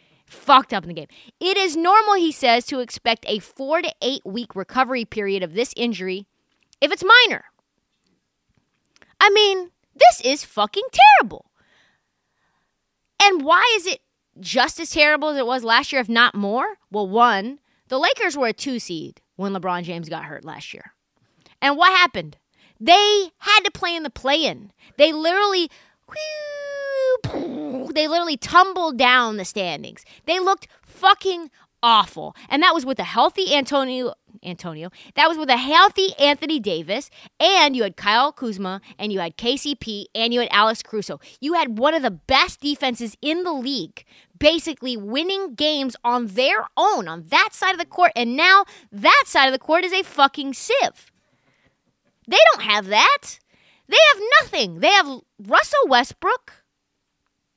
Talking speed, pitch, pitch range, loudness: 165 wpm, 280 Hz, 230-340 Hz, -18 LUFS